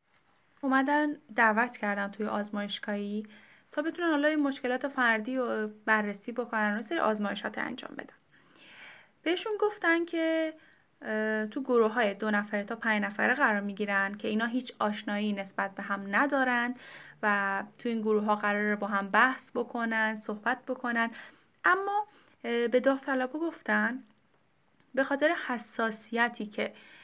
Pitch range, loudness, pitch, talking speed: 210-270 Hz, -30 LUFS, 230 Hz, 135 wpm